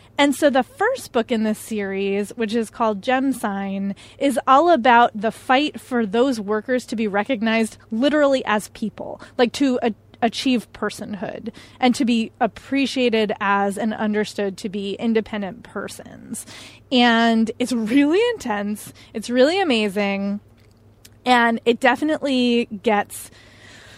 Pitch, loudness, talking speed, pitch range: 230 Hz, -20 LUFS, 135 wpm, 210-255 Hz